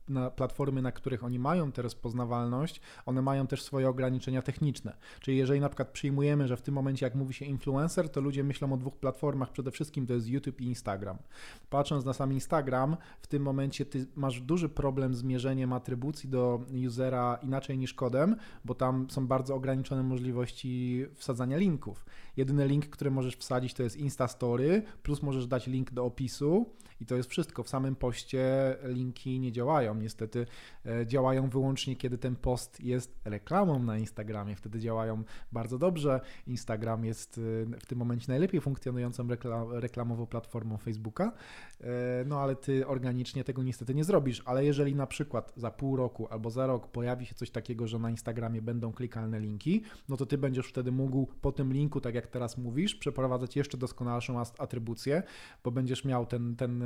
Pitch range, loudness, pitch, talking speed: 120-135 Hz, -33 LUFS, 130 Hz, 175 wpm